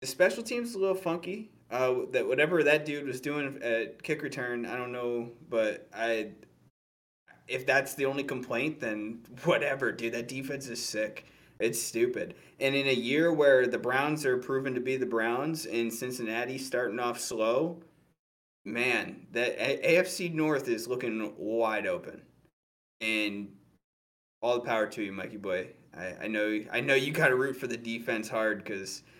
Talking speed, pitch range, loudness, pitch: 170 wpm, 115-145 Hz, -30 LUFS, 125 Hz